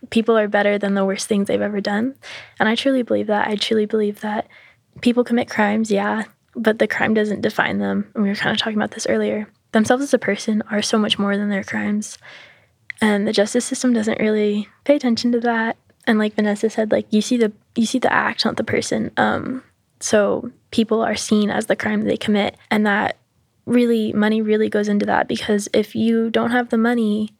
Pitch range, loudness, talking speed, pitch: 210-230 Hz, -19 LUFS, 215 wpm, 215 Hz